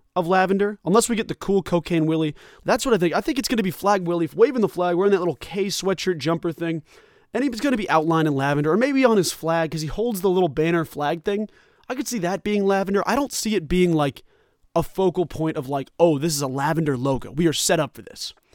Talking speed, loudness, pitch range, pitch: 260 wpm, -22 LUFS, 160-205 Hz, 180 Hz